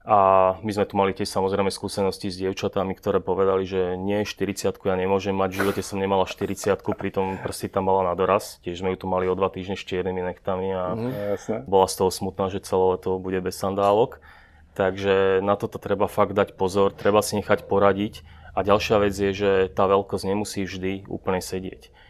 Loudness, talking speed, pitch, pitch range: -24 LUFS, 200 wpm, 95 Hz, 95-100 Hz